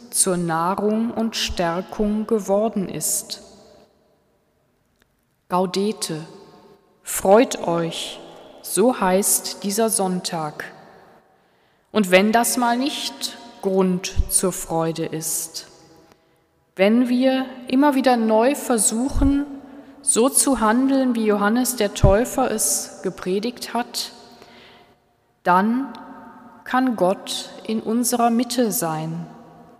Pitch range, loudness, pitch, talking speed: 185-245 Hz, -20 LUFS, 210 Hz, 90 wpm